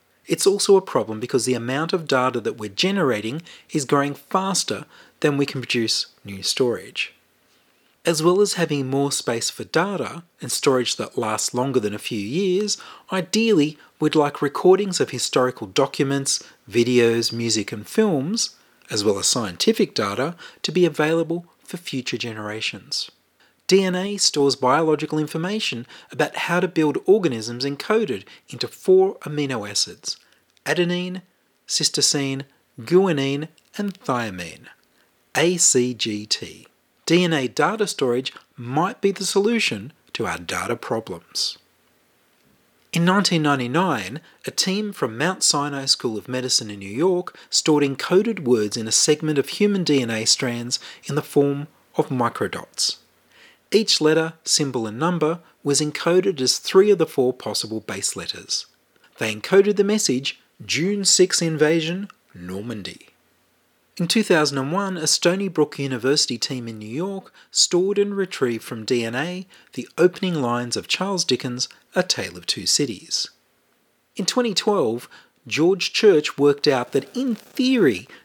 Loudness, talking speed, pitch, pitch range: -21 LUFS, 140 wpm, 150 Hz, 125-185 Hz